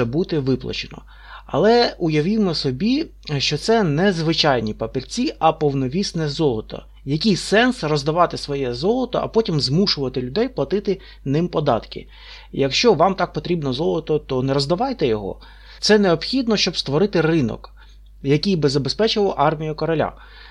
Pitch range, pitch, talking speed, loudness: 140-200 Hz, 160 Hz, 130 wpm, -20 LUFS